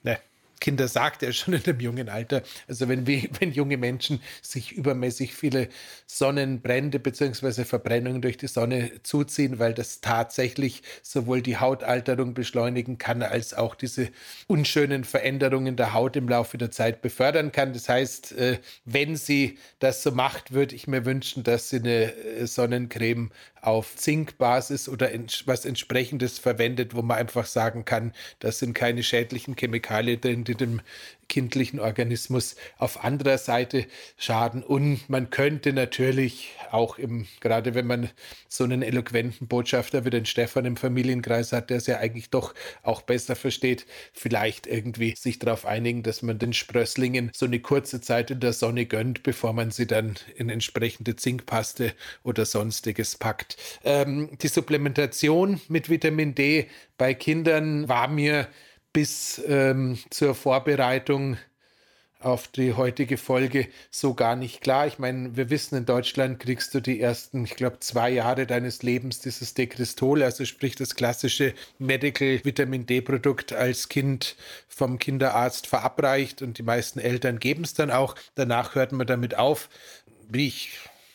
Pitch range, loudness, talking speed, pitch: 120-135 Hz, -26 LUFS, 155 wpm, 125 Hz